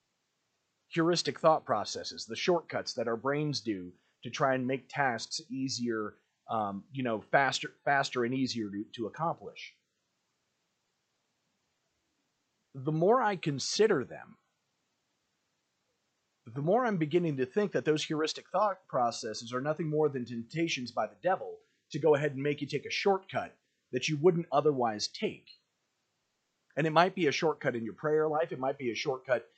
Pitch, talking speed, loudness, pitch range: 145 Hz, 160 wpm, -31 LUFS, 125-160 Hz